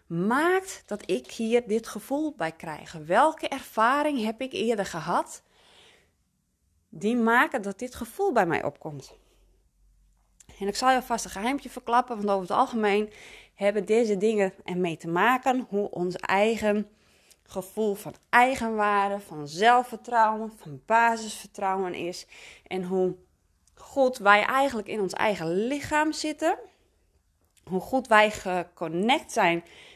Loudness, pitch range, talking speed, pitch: -26 LUFS, 180-245 Hz, 130 wpm, 210 Hz